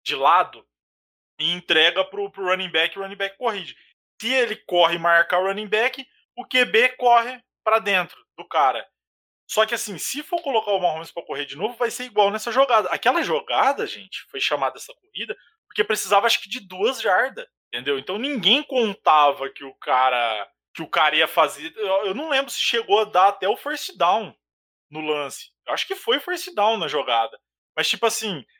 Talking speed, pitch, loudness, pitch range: 195 wpm, 205 Hz, -21 LUFS, 170-245 Hz